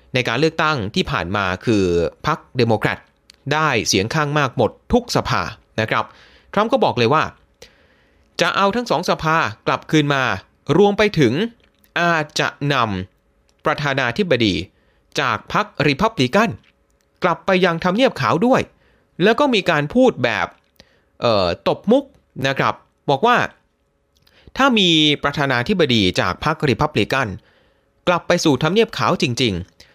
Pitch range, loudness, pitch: 110-170 Hz, -18 LUFS, 145 Hz